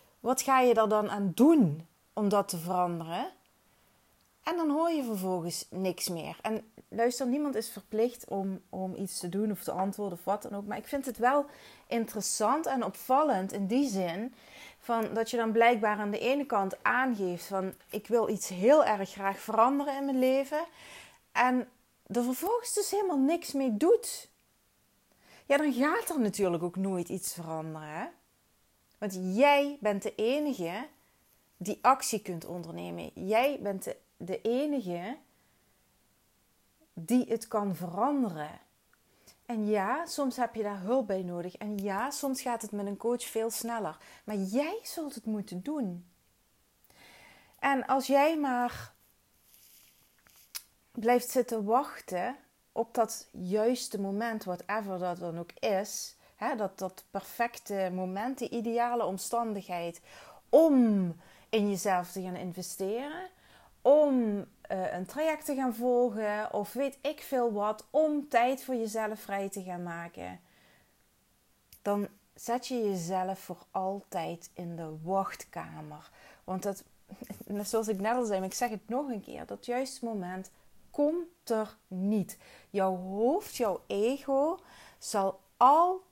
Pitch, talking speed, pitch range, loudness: 220 Hz, 145 wpm, 190-255 Hz, -31 LUFS